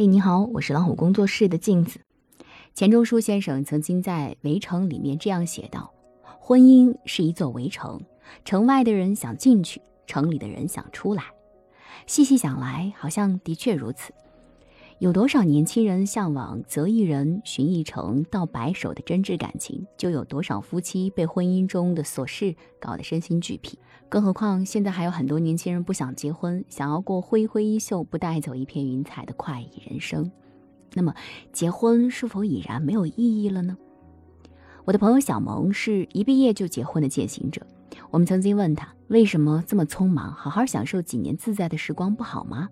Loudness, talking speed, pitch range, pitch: -23 LUFS, 275 characters per minute, 145-205 Hz, 175 Hz